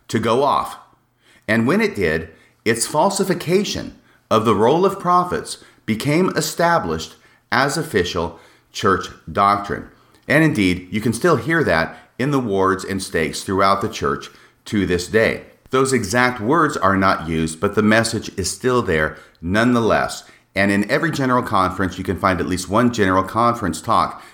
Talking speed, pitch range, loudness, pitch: 160 wpm, 95-130 Hz, -19 LUFS, 110 Hz